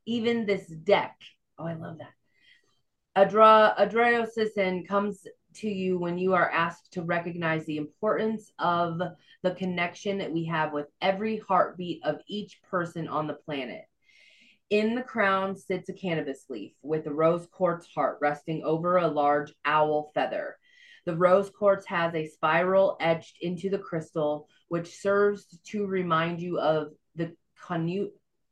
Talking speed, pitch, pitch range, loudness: 150 wpm, 175 Hz, 160-200 Hz, -27 LUFS